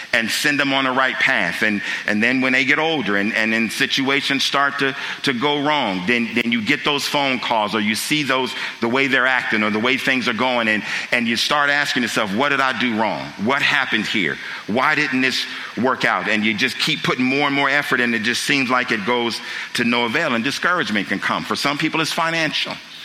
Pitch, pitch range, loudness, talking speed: 130 Hz, 115-145 Hz, -18 LUFS, 235 wpm